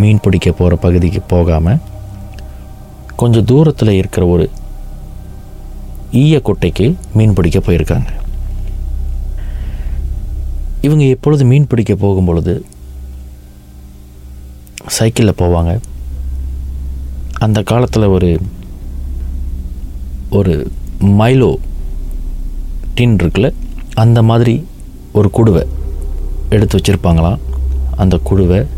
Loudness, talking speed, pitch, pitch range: -13 LUFS, 75 wpm, 85 Hz, 65-100 Hz